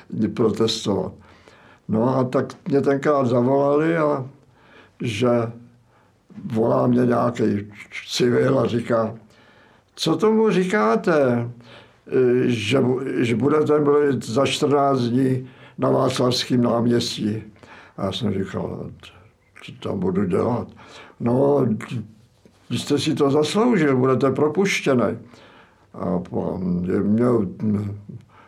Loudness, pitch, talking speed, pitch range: -21 LUFS, 125 Hz, 95 wpm, 115-140 Hz